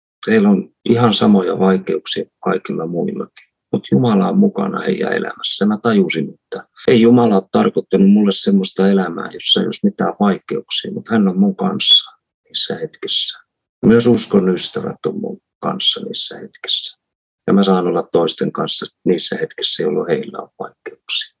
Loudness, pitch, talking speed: -16 LUFS, 120 Hz, 155 wpm